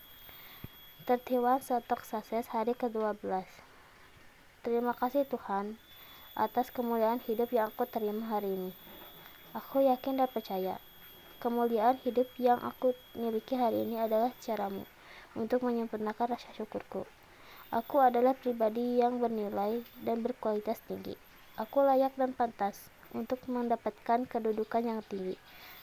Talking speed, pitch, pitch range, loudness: 115 wpm, 235 Hz, 220-245 Hz, -33 LUFS